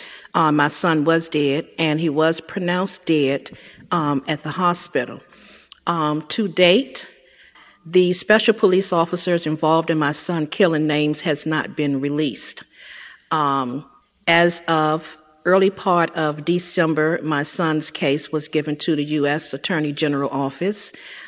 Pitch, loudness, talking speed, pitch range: 155 Hz, -20 LUFS, 140 wpm, 150-175 Hz